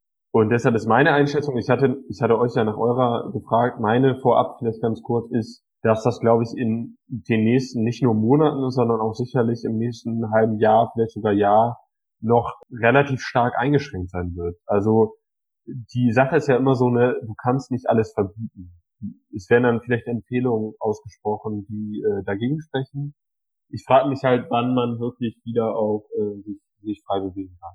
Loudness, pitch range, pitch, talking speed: -21 LUFS, 110-125 Hz, 115 Hz, 180 wpm